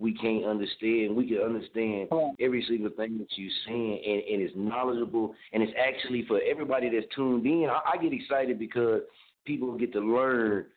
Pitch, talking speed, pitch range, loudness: 115 Hz, 185 wpm, 110-125 Hz, -29 LUFS